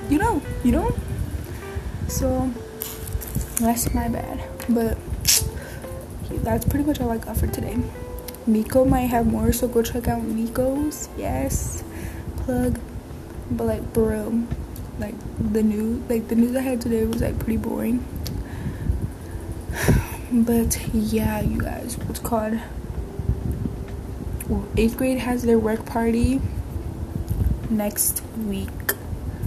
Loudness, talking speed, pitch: -24 LUFS, 120 wpm, 215 Hz